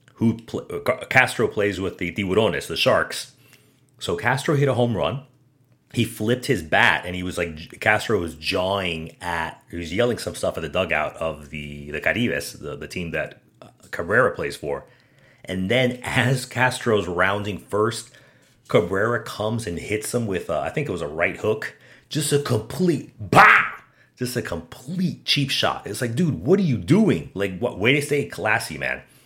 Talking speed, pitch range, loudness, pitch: 185 wpm, 95-130 Hz, -22 LUFS, 120 Hz